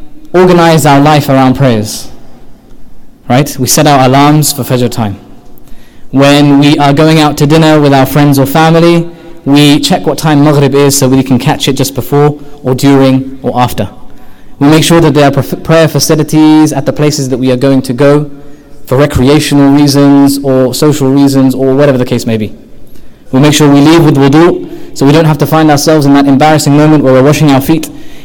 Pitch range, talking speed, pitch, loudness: 135-150 Hz, 200 wpm, 145 Hz, -6 LUFS